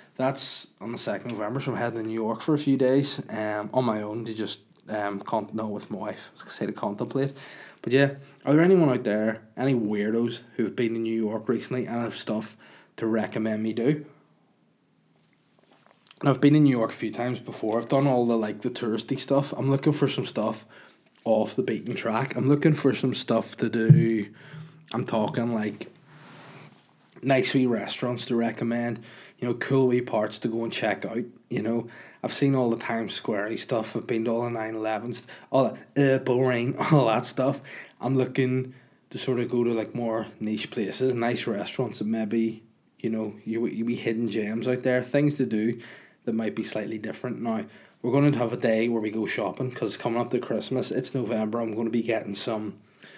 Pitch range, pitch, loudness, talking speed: 110-130 Hz, 120 Hz, -26 LUFS, 205 wpm